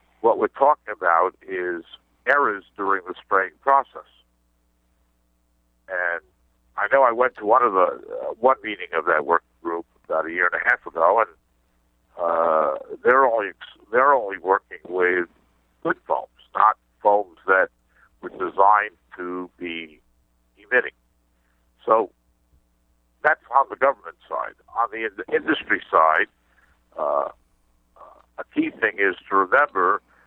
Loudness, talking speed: -22 LUFS, 135 wpm